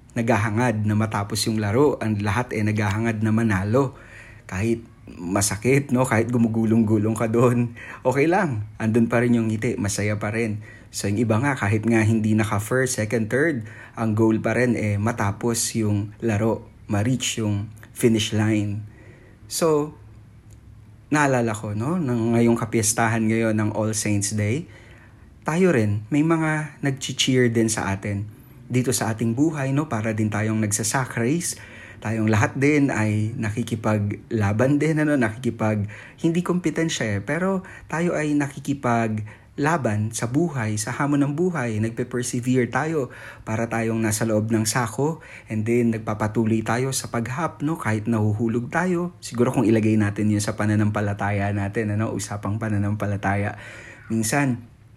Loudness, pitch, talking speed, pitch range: -23 LUFS, 115 Hz, 145 wpm, 110-125 Hz